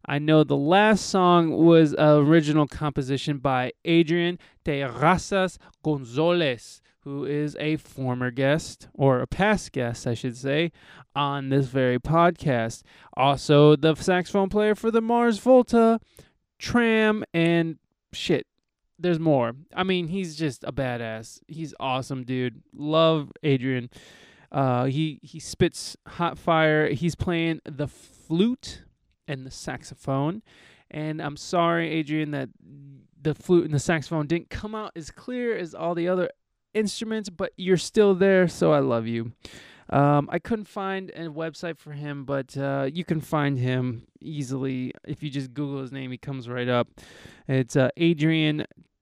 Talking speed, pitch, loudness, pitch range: 150 wpm, 155 Hz, -24 LUFS, 135-175 Hz